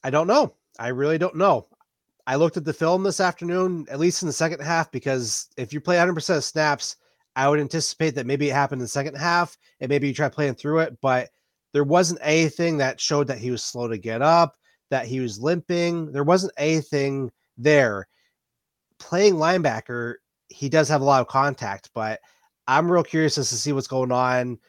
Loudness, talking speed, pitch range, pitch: -22 LUFS, 205 wpm, 130-165 Hz, 145 Hz